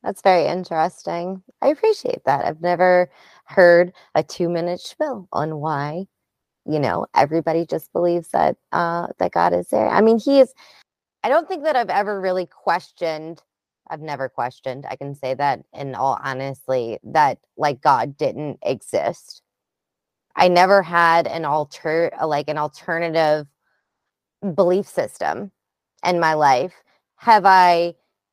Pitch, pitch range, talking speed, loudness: 170 Hz, 145-185 Hz, 145 wpm, -20 LUFS